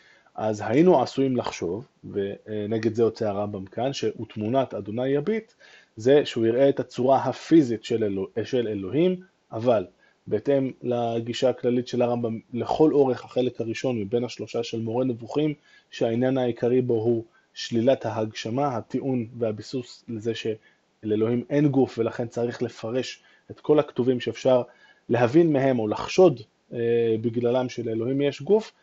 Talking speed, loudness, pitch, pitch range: 135 wpm, -25 LUFS, 120 Hz, 115-135 Hz